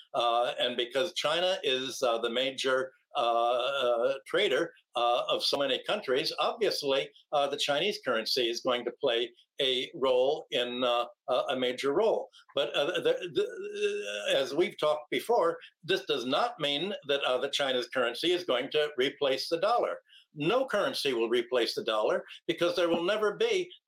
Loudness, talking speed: -29 LUFS, 170 wpm